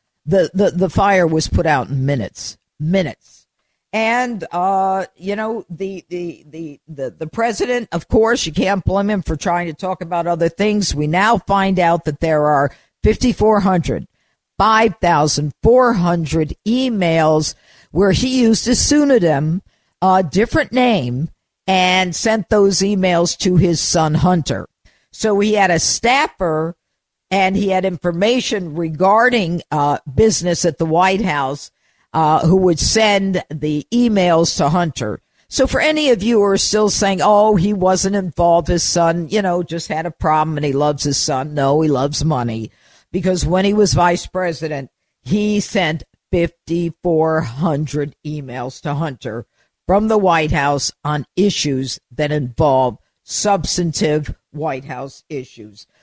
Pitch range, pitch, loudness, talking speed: 155-200 Hz, 175 Hz, -16 LUFS, 145 wpm